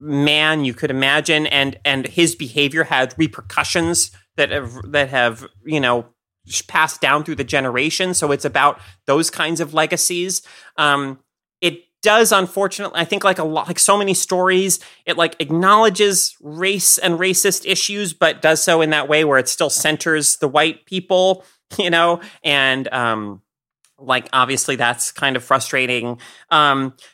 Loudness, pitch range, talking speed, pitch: -17 LUFS, 135-175 Hz, 160 wpm, 150 Hz